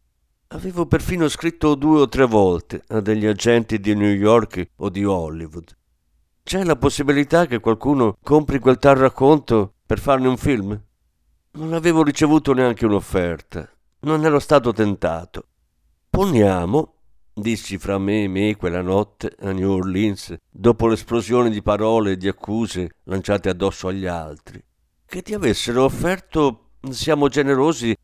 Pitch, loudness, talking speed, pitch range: 110 Hz, -19 LUFS, 140 wpm, 95-140 Hz